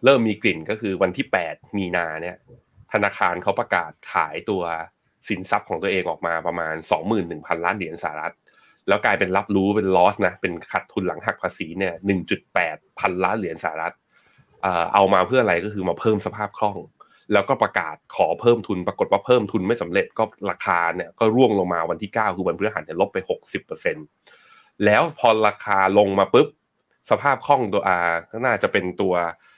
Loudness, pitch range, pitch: -22 LUFS, 90-120 Hz, 100 Hz